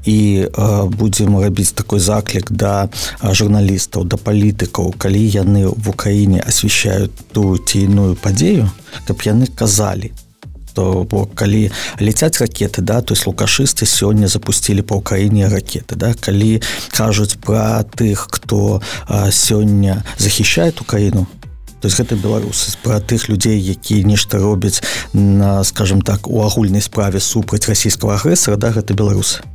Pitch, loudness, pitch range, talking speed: 105 Hz, -14 LUFS, 100-110 Hz, 125 wpm